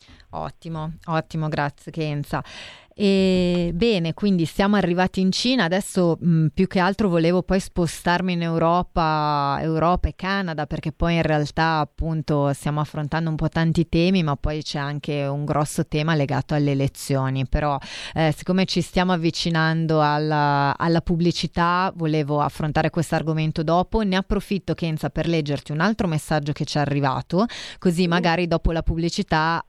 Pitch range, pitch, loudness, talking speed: 150-180 Hz, 160 Hz, -22 LUFS, 155 wpm